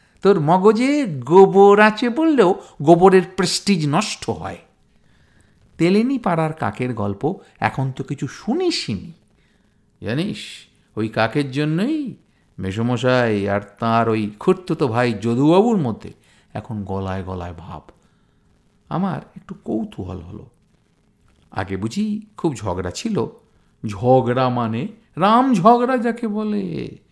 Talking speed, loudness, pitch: 110 wpm, -18 LUFS, 145 Hz